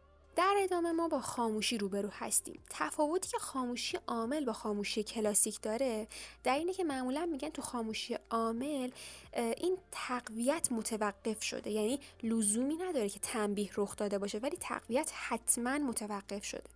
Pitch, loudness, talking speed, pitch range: 240 Hz, -35 LUFS, 145 wpm, 215-295 Hz